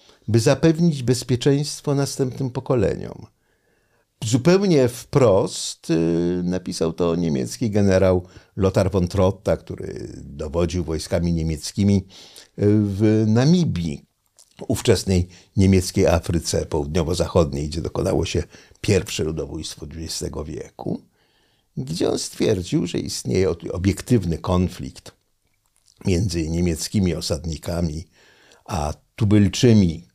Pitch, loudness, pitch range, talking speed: 95 Hz, -21 LUFS, 85-115 Hz, 85 wpm